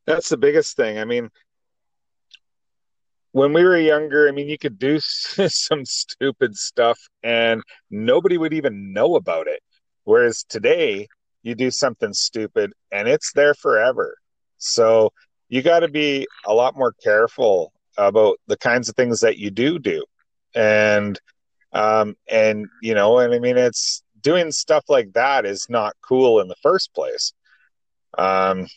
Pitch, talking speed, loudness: 145 Hz, 155 wpm, -19 LUFS